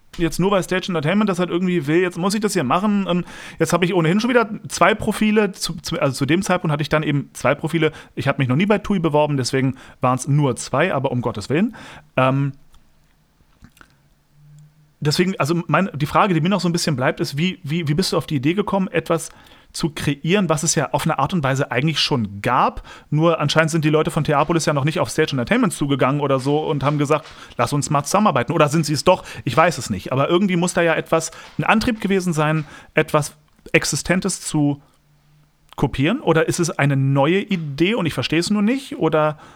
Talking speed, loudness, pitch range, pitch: 225 wpm, -19 LUFS, 145-180 Hz, 160 Hz